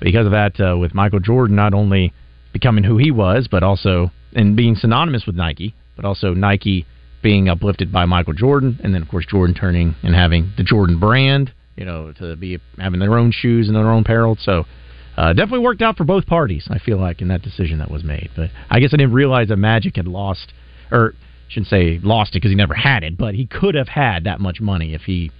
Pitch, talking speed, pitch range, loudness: 100 Hz, 230 wpm, 90-115 Hz, -16 LUFS